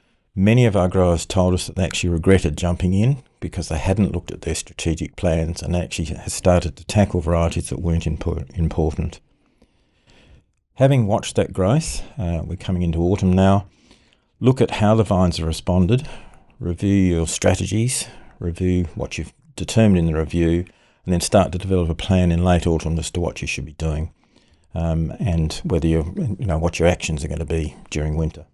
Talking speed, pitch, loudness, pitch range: 185 wpm, 90 Hz, -20 LUFS, 80-95 Hz